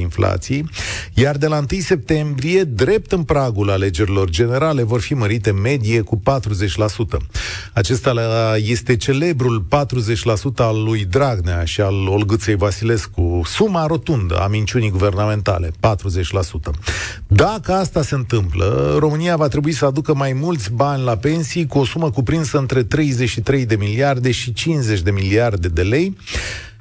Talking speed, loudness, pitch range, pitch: 140 wpm, -18 LUFS, 100-140 Hz, 115 Hz